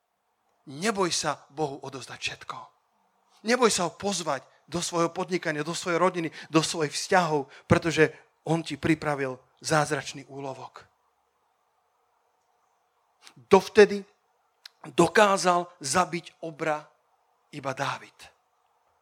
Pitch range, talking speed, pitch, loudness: 150-180 Hz, 95 wpm, 165 Hz, -26 LUFS